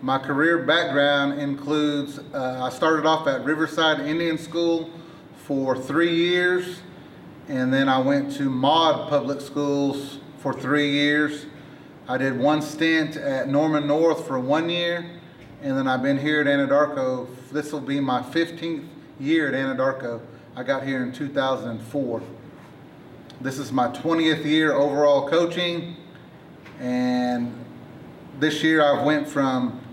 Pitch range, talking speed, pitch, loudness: 135-160 Hz, 135 wpm, 145 Hz, -23 LUFS